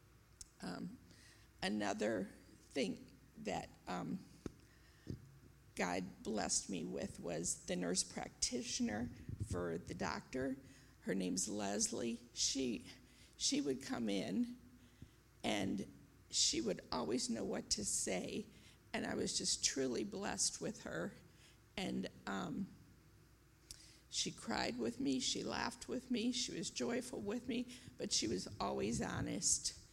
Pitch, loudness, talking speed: 120 Hz, -41 LUFS, 120 wpm